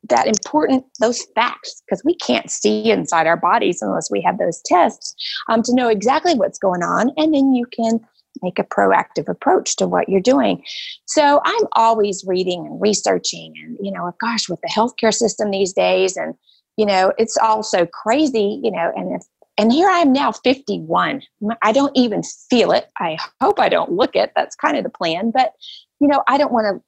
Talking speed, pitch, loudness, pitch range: 205 wpm, 225 Hz, -17 LUFS, 200-270 Hz